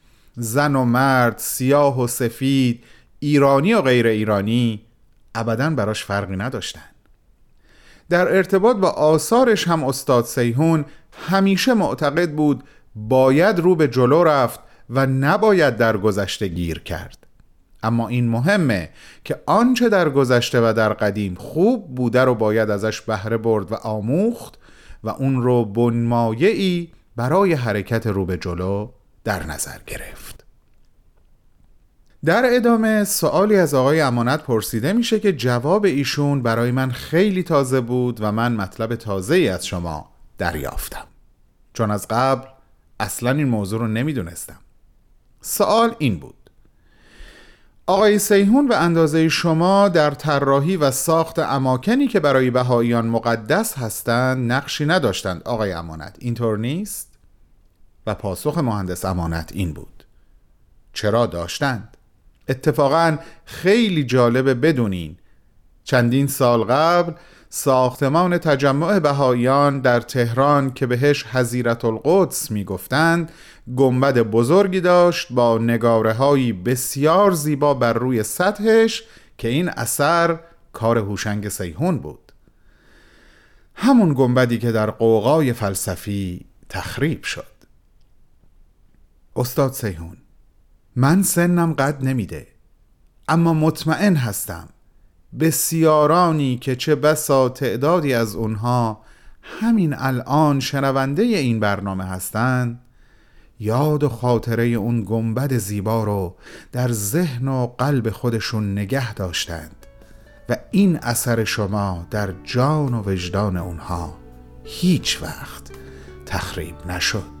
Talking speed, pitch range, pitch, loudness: 115 wpm, 110-155 Hz, 125 Hz, -19 LUFS